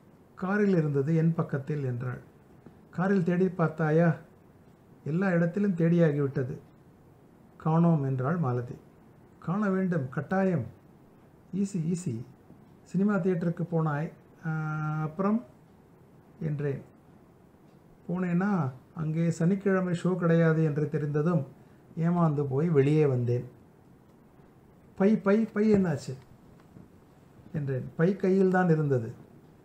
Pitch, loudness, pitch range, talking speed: 165 Hz, -28 LUFS, 145-180 Hz, 90 wpm